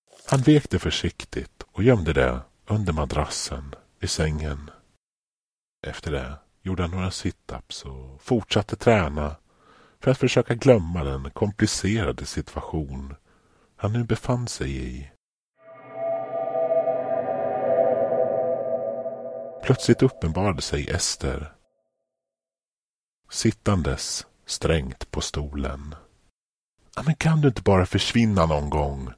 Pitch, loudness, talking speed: 100 Hz, -24 LUFS, 100 wpm